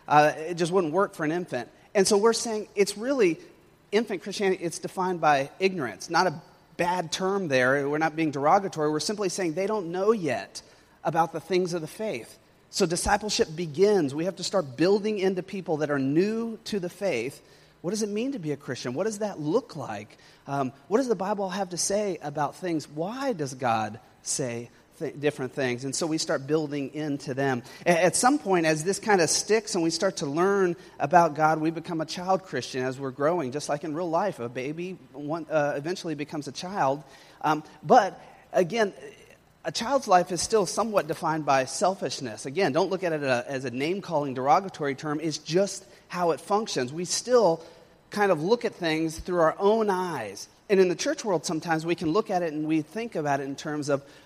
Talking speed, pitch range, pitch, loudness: 205 wpm, 150-195 Hz, 170 Hz, -26 LUFS